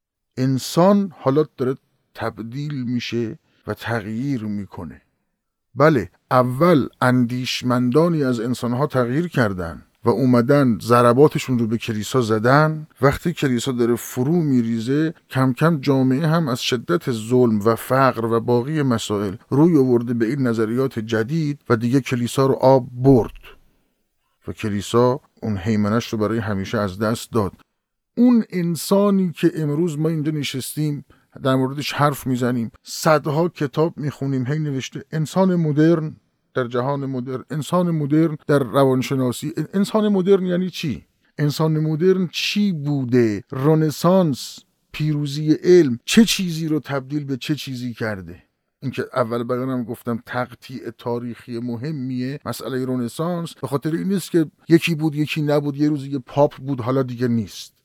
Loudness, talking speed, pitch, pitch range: -20 LUFS, 135 wpm, 135 Hz, 120-155 Hz